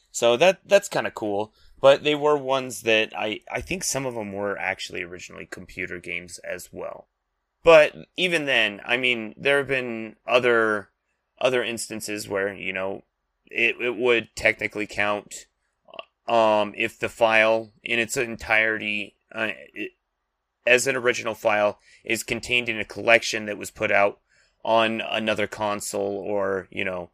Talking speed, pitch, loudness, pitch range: 155 wpm, 110 Hz, -23 LUFS, 100-120 Hz